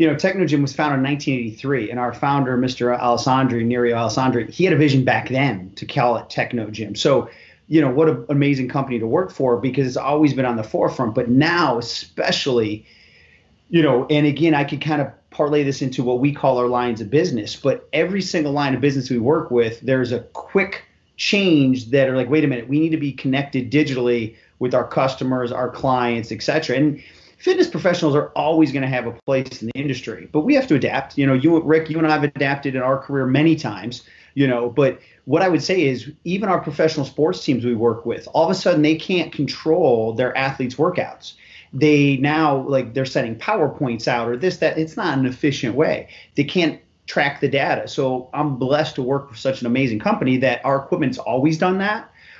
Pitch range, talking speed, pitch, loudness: 125-150 Hz, 215 wpm, 135 Hz, -19 LUFS